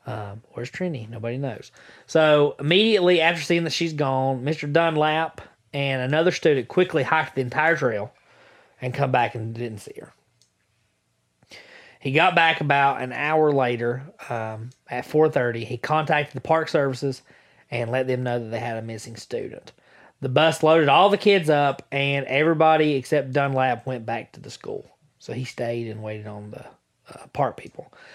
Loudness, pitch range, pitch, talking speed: -22 LUFS, 120-155 Hz, 135 Hz, 170 wpm